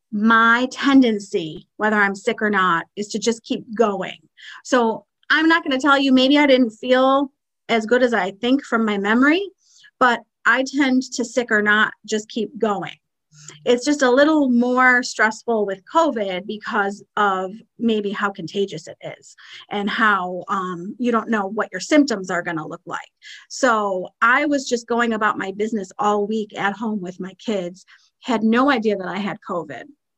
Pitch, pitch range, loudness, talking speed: 220 Hz, 200-255 Hz, -19 LUFS, 185 wpm